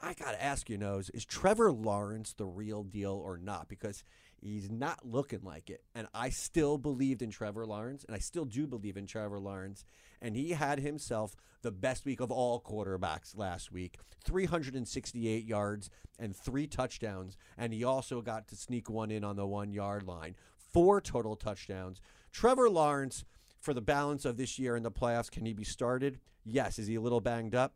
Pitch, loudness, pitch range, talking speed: 110 Hz, -36 LUFS, 100-130 Hz, 195 wpm